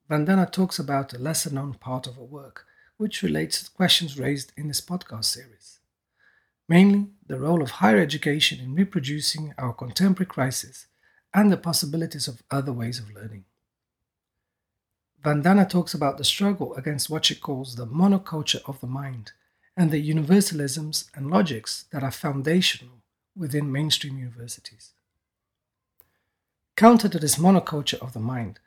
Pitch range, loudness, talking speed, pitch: 120-165 Hz, -23 LUFS, 145 wpm, 140 Hz